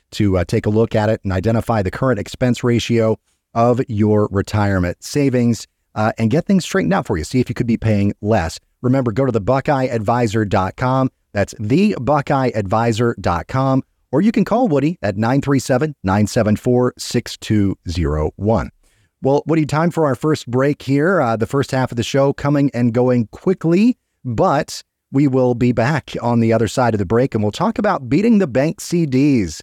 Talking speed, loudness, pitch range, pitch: 175 wpm, -17 LUFS, 110-140 Hz, 120 Hz